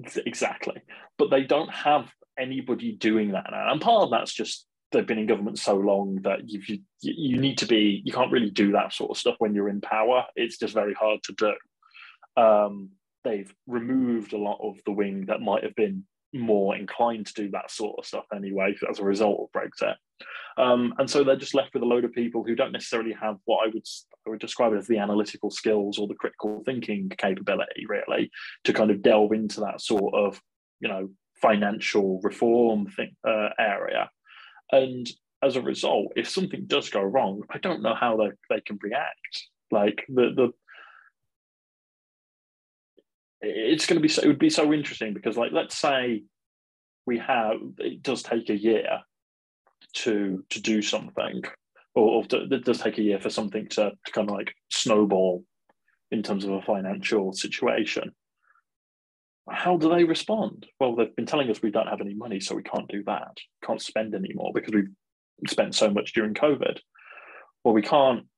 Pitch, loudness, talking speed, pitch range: 110 Hz, -26 LUFS, 190 wpm, 100-125 Hz